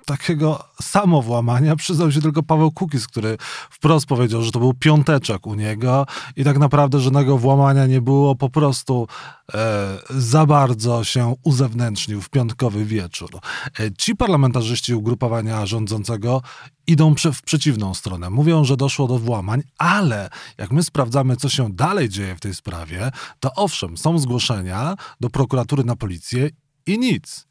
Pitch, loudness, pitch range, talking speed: 130 Hz, -19 LUFS, 115-150 Hz, 145 wpm